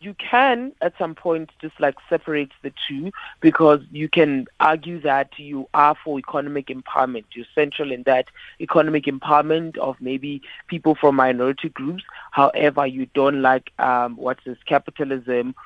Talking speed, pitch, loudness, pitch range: 155 wpm, 145 Hz, -20 LUFS, 130-160 Hz